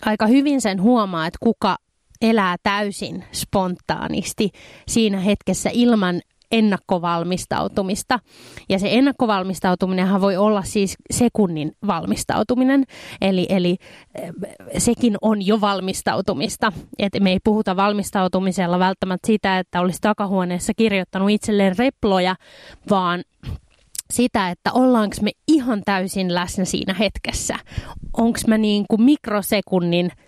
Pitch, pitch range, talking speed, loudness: 200 Hz, 185-225 Hz, 105 wpm, -20 LUFS